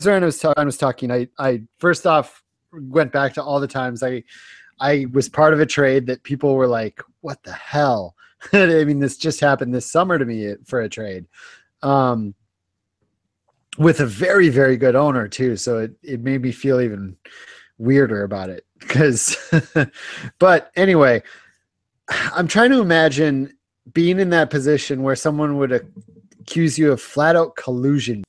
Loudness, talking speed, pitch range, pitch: -18 LUFS, 170 wpm, 125-155 Hz, 140 Hz